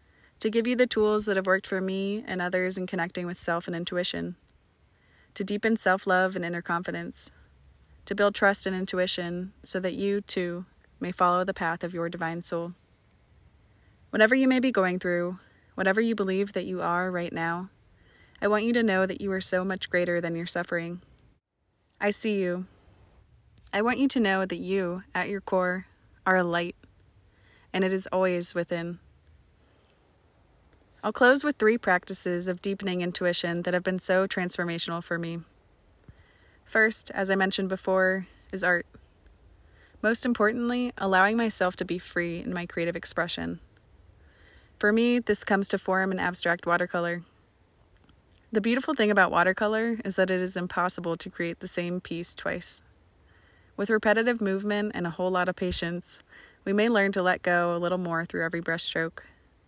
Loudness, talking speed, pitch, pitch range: -27 LUFS, 170 wpm, 180 Hz, 170-195 Hz